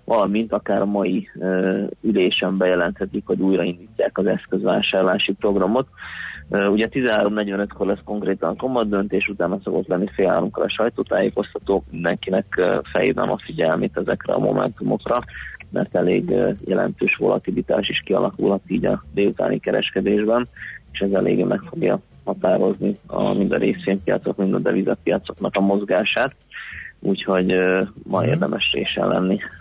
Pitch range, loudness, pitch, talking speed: 95-100 Hz, -21 LUFS, 100 Hz, 135 wpm